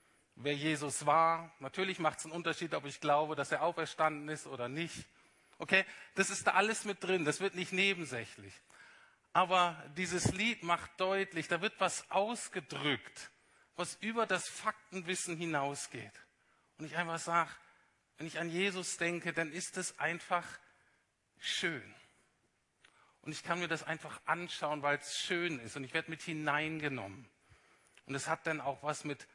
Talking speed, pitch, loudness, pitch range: 160 wpm, 165 Hz, -36 LUFS, 150-185 Hz